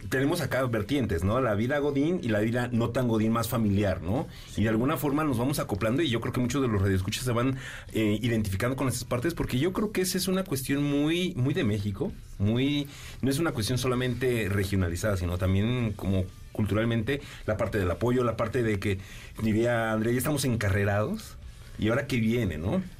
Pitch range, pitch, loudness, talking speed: 105-135 Hz, 115 Hz, -28 LUFS, 205 wpm